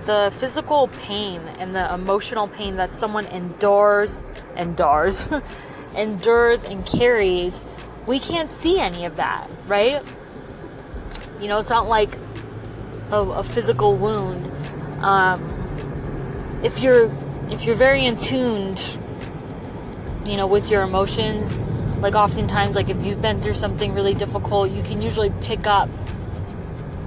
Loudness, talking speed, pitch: -21 LUFS, 130 wpm, 195 Hz